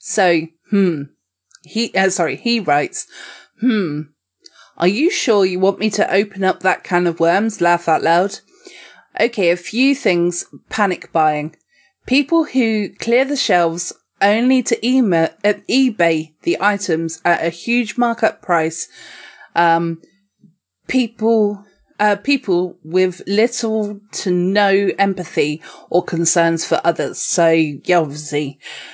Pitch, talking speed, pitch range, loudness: 190 Hz, 135 wpm, 170-220 Hz, -17 LUFS